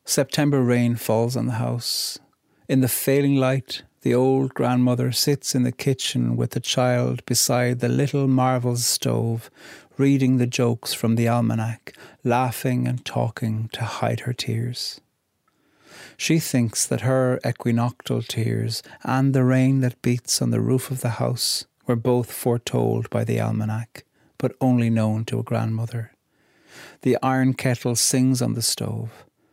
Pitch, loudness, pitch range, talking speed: 125 Hz, -22 LUFS, 115-130 Hz, 150 wpm